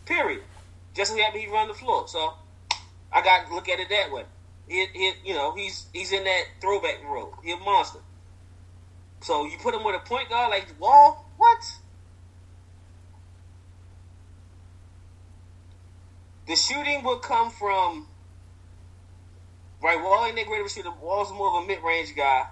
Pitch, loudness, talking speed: 90 Hz, -24 LUFS, 145 wpm